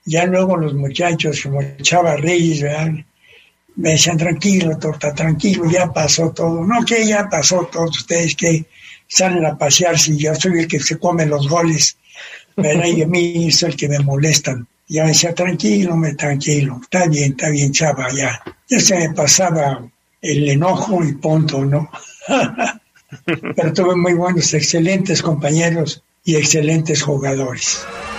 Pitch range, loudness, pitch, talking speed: 150-175 Hz, -15 LUFS, 160 Hz, 155 wpm